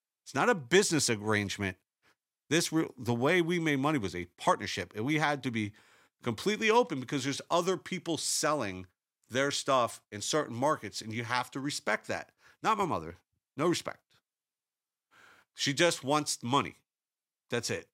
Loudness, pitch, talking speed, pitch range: -31 LUFS, 140 Hz, 160 wpm, 110-160 Hz